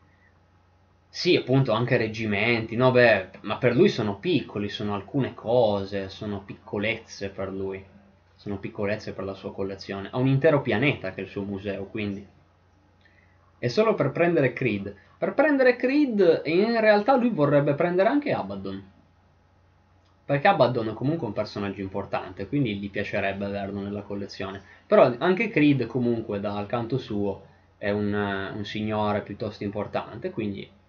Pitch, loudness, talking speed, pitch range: 105 Hz, -25 LUFS, 150 wpm, 95-125 Hz